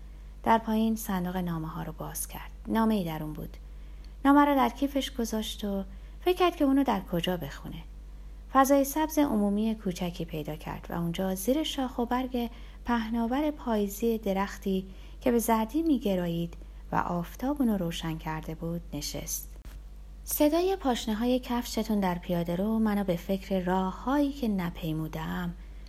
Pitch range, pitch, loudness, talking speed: 170-245 Hz, 200 Hz, -29 LUFS, 155 wpm